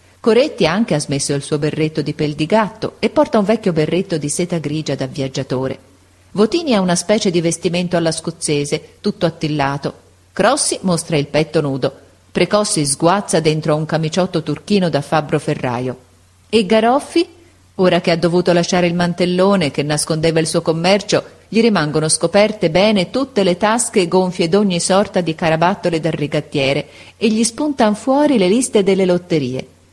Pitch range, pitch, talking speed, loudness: 150-200 Hz, 170 Hz, 160 wpm, -16 LUFS